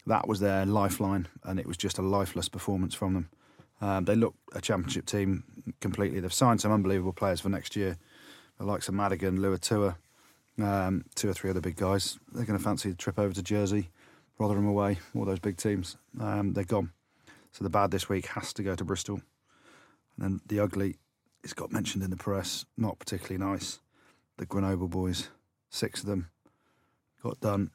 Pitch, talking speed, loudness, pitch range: 100 Hz, 195 wpm, -31 LUFS, 95-105 Hz